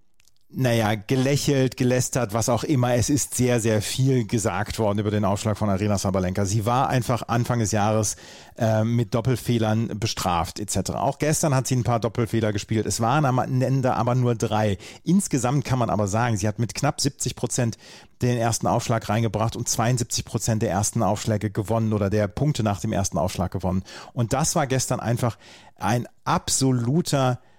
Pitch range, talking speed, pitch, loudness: 105-125 Hz, 175 wpm, 115 Hz, -23 LUFS